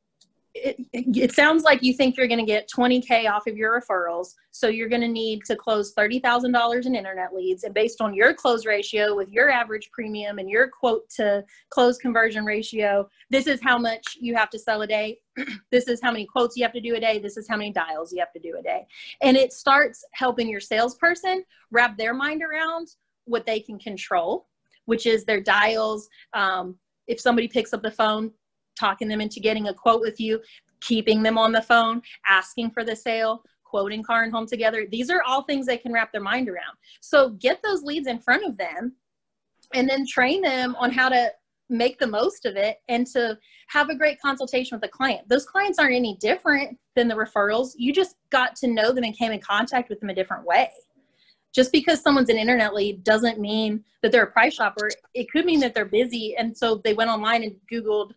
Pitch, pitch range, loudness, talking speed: 230 Hz, 215-255 Hz, -23 LUFS, 220 wpm